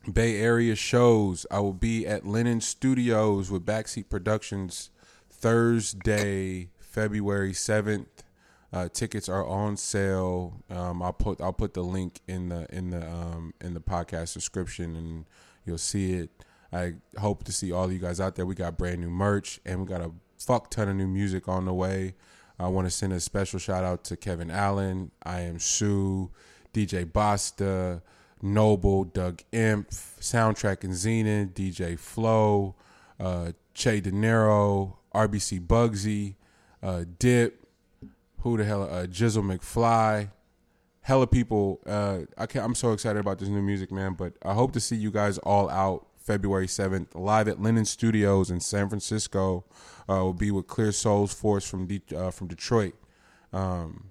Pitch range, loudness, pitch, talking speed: 90-105 Hz, -28 LUFS, 100 Hz, 165 wpm